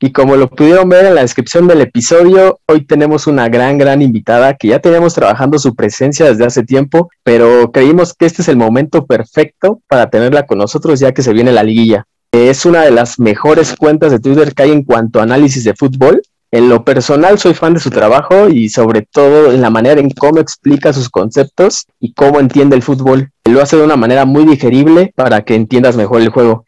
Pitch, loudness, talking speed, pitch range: 135 Hz, -8 LUFS, 215 wpm, 120-155 Hz